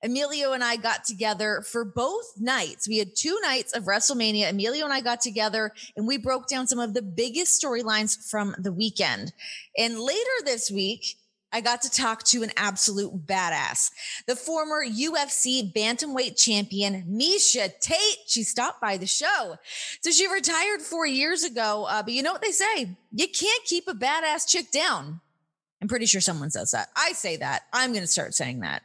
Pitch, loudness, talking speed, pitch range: 235 Hz, -24 LUFS, 185 wpm, 210-300 Hz